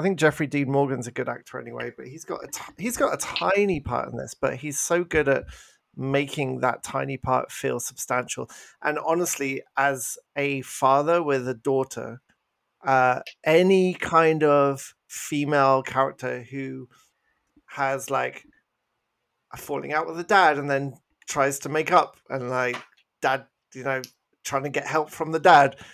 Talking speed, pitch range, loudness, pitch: 170 wpm, 130-155 Hz, -24 LUFS, 140 Hz